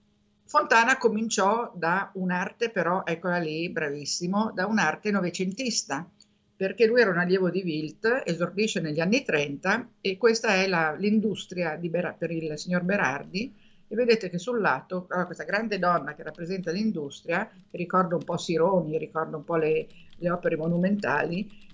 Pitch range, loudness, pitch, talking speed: 165-210 Hz, -26 LUFS, 185 Hz, 150 wpm